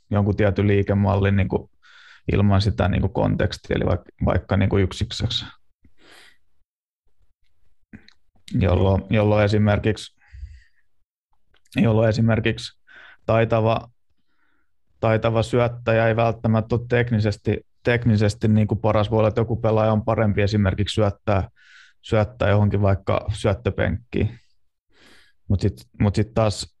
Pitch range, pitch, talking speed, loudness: 100-110 Hz, 105 Hz, 110 wpm, -21 LUFS